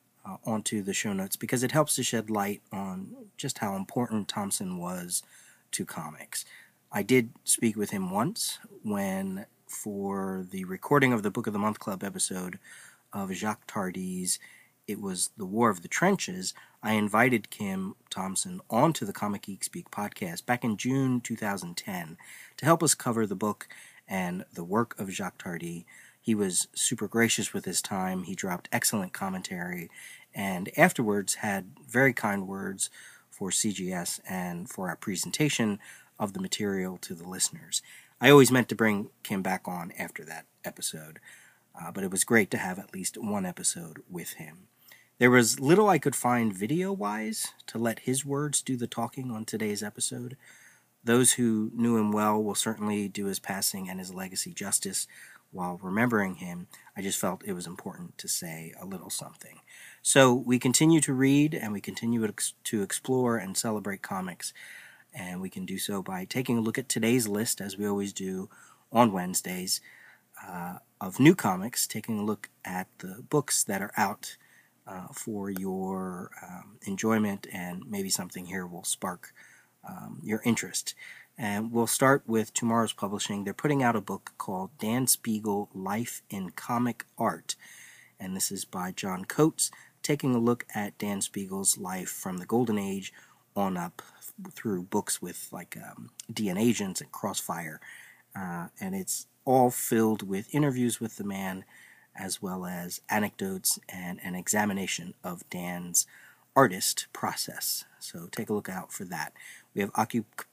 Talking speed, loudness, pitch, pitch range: 165 wpm, -29 LUFS, 110 Hz, 95-130 Hz